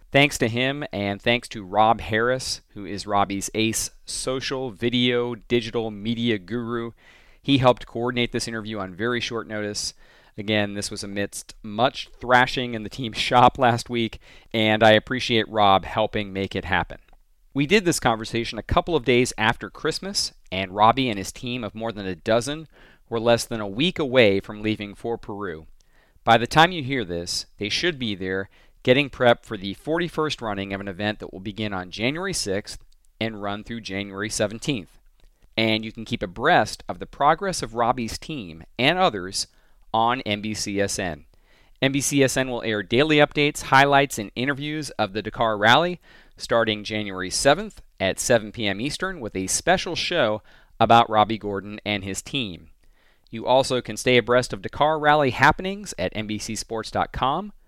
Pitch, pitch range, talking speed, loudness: 115 Hz, 105-130 Hz, 165 wpm, -23 LUFS